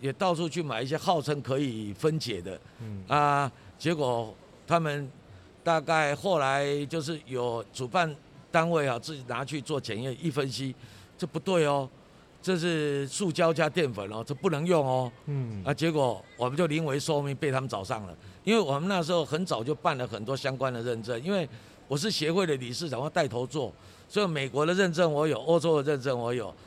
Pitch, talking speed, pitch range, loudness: 145 Hz, 280 characters per minute, 125-165 Hz, -29 LUFS